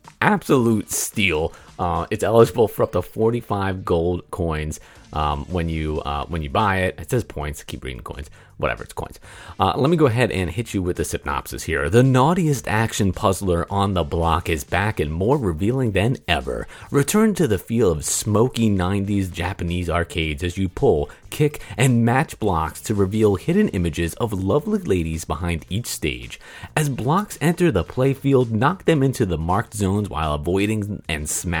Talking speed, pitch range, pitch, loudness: 180 wpm, 85-120 Hz, 100 Hz, -21 LUFS